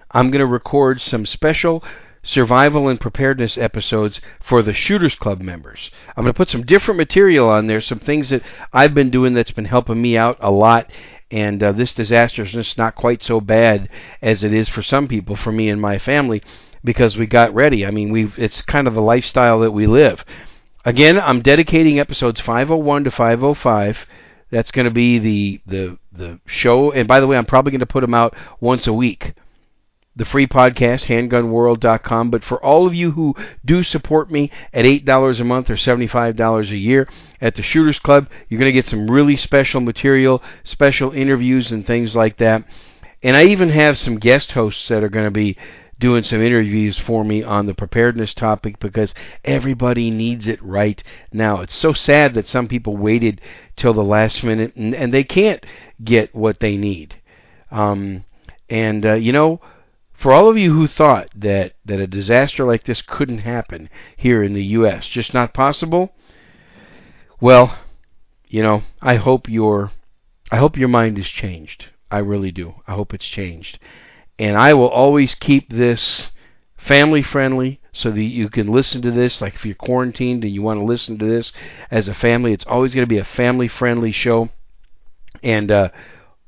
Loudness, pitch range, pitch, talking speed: -15 LUFS, 105-130 Hz, 115 Hz, 190 wpm